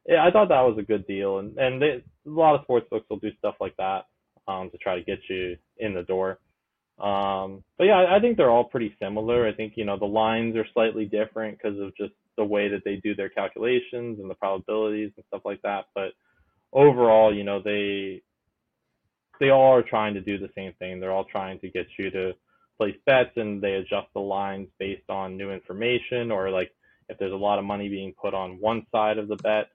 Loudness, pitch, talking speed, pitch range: -25 LUFS, 105 Hz, 230 wpm, 95-115 Hz